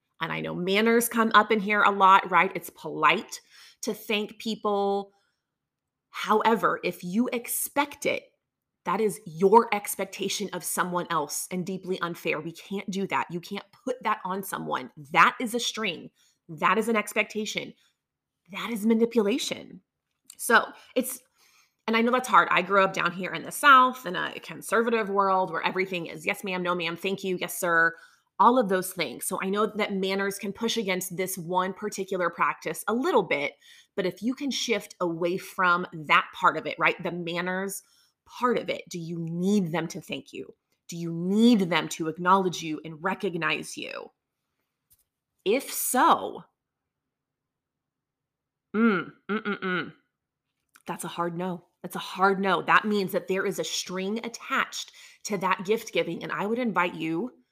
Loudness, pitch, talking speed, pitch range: -26 LUFS, 195 Hz, 175 wpm, 175-220 Hz